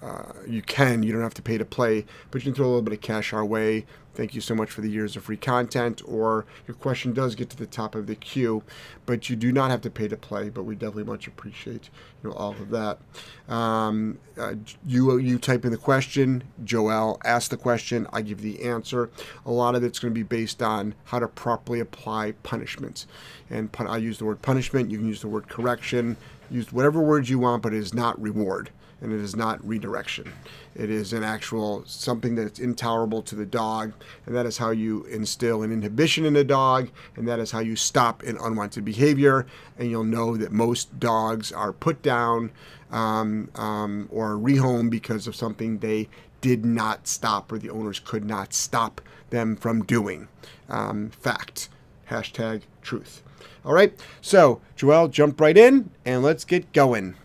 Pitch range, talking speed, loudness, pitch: 110-125 Hz, 200 wpm, -24 LUFS, 115 Hz